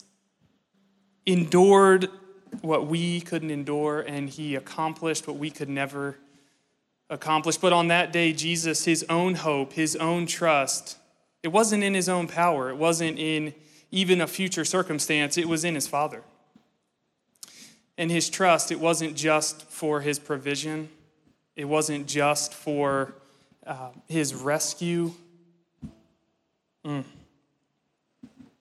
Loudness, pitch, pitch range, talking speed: -25 LUFS, 160 Hz, 150-175 Hz, 125 wpm